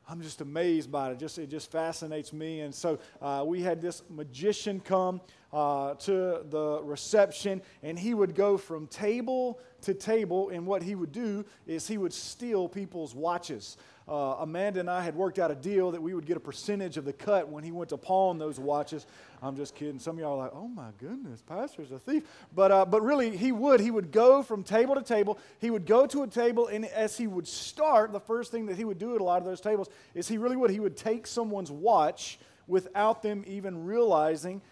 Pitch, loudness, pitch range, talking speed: 190 Hz, -30 LUFS, 160-215 Hz, 225 wpm